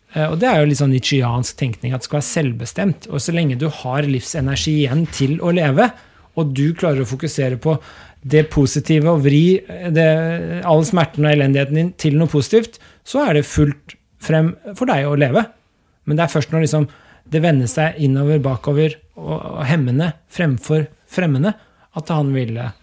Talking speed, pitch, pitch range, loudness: 180 wpm, 155 Hz, 140-165 Hz, -17 LUFS